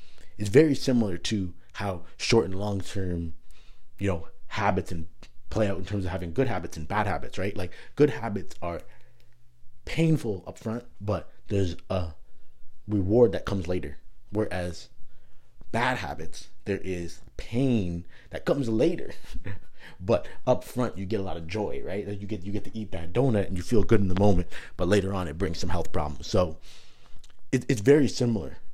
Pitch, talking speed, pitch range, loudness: 100 Hz, 180 wpm, 90-110 Hz, -28 LUFS